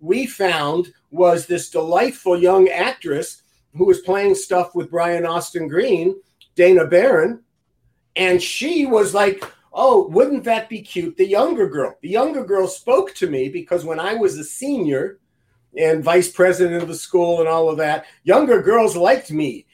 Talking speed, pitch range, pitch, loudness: 165 wpm, 170-280 Hz, 185 Hz, -18 LUFS